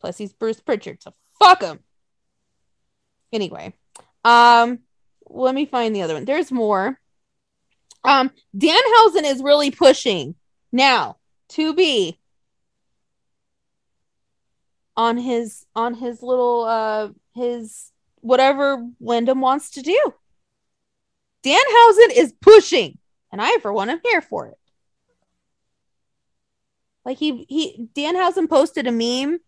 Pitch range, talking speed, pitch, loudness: 235-325 Hz, 120 wpm, 265 Hz, -17 LUFS